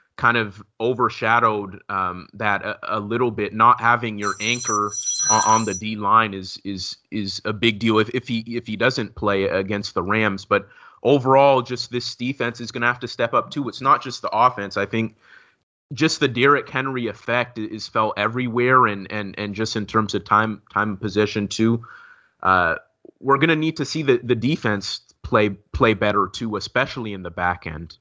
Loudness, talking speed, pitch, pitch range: -21 LUFS, 200 wpm, 110 Hz, 105-120 Hz